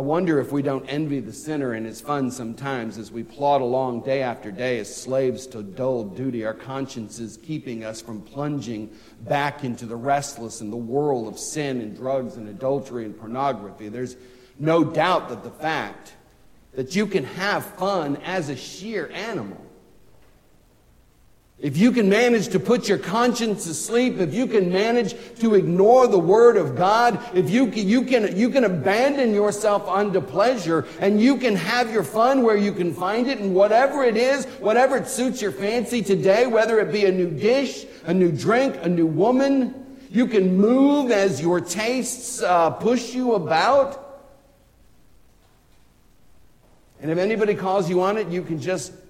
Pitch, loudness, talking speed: 185 Hz, -21 LUFS, 175 wpm